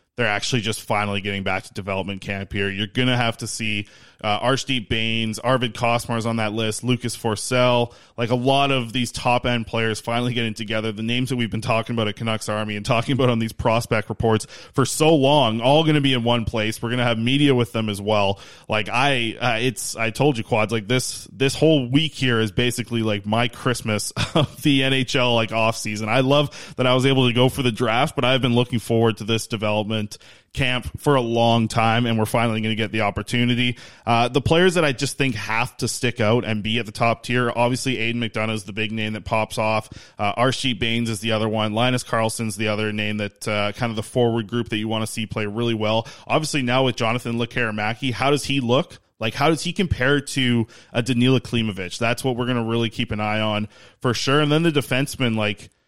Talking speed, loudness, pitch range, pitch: 230 wpm, -21 LUFS, 110-125 Hz, 115 Hz